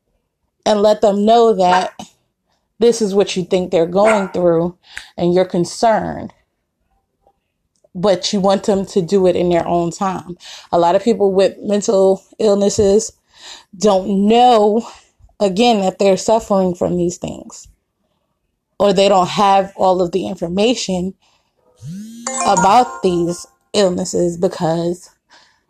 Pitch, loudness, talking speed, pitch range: 195 Hz, -15 LUFS, 130 wpm, 180-210 Hz